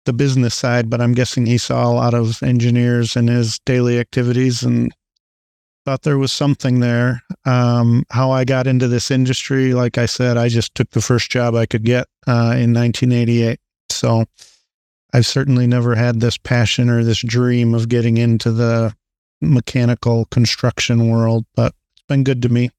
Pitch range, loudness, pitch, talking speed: 115-125 Hz, -16 LUFS, 120 Hz, 175 wpm